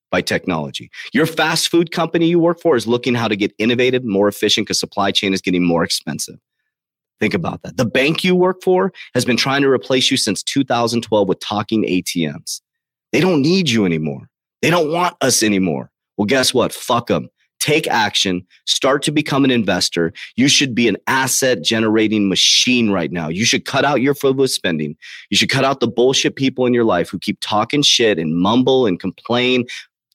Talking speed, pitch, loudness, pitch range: 195 wpm, 120 Hz, -16 LUFS, 100-135 Hz